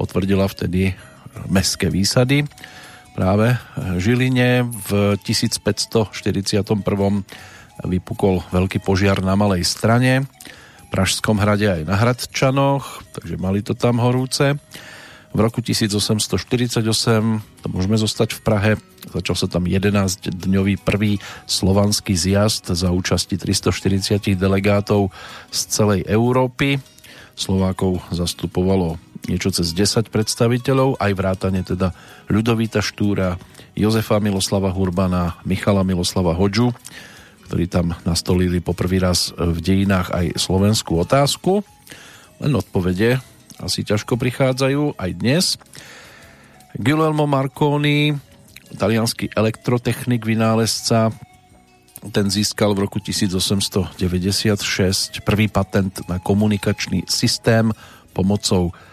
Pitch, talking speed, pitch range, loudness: 100 Hz, 100 wpm, 95-115 Hz, -19 LUFS